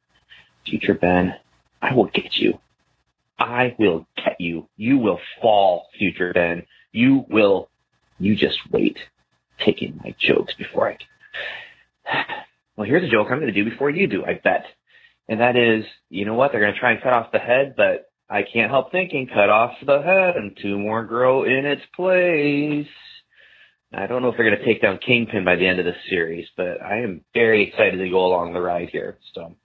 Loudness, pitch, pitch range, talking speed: -20 LUFS, 115 Hz, 95-150 Hz, 200 wpm